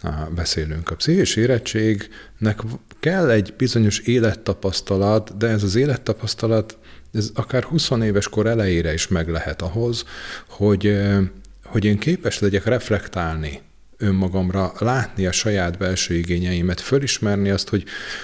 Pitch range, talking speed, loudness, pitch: 95-115 Hz, 125 wpm, -21 LUFS, 105 Hz